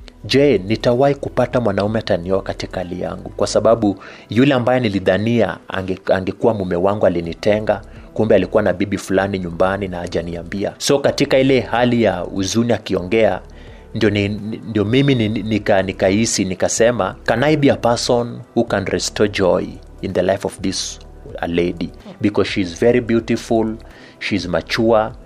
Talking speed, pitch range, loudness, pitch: 140 wpm, 95-115 Hz, -18 LUFS, 100 Hz